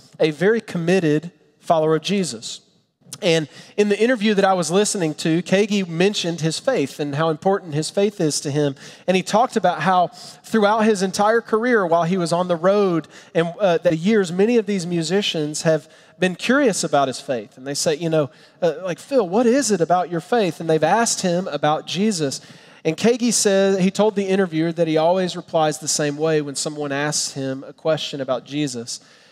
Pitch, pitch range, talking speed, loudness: 175 Hz, 155-200 Hz, 200 wpm, -20 LUFS